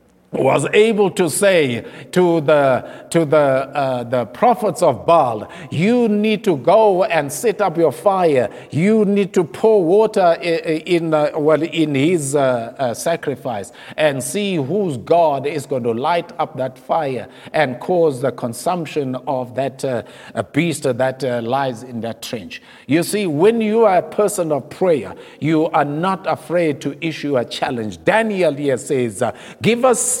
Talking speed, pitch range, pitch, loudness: 165 wpm, 130-190 Hz, 155 Hz, -17 LUFS